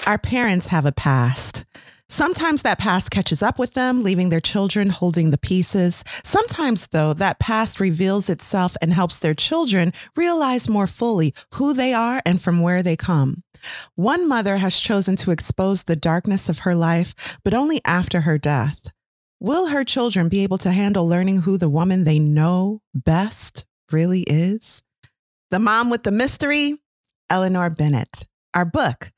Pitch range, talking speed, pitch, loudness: 165-220 Hz, 165 wpm, 185 Hz, -19 LUFS